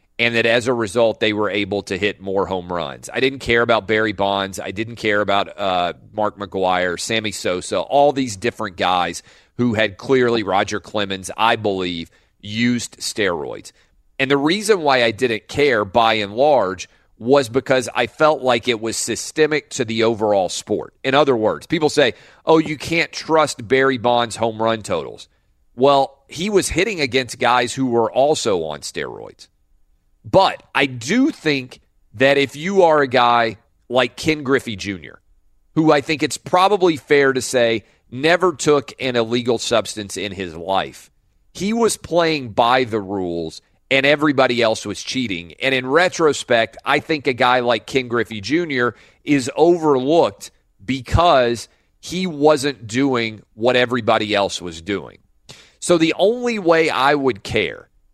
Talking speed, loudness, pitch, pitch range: 165 wpm, -18 LUFS, 120 Hz, 105-140 Hz